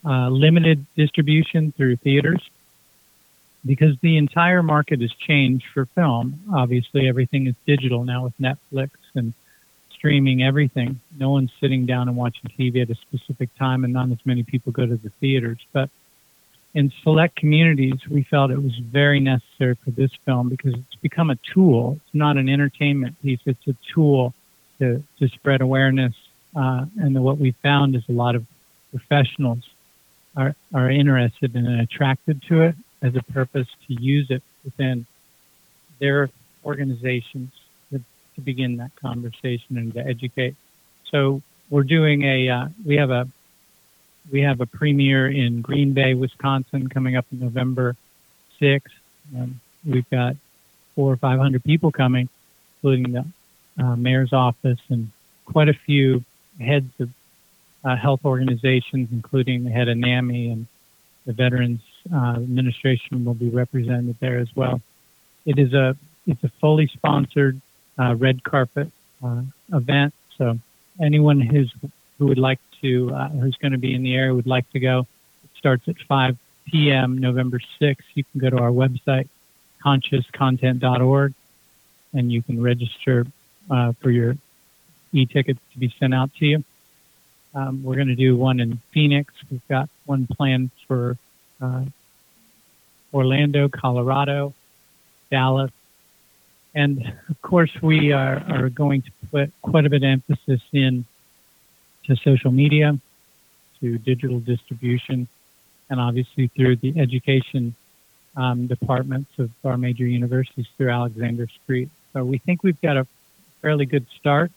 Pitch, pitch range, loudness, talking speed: 130 Hz, 125-145 Hz, -21 LUFS, 150 wpm